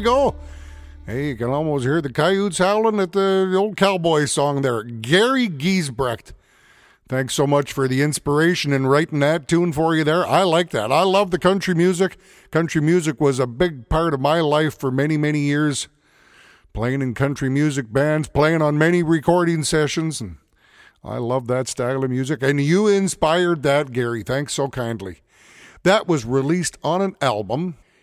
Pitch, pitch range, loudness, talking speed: 150 Hz, 130-170 Hz, -19 LUFS, 180 wpm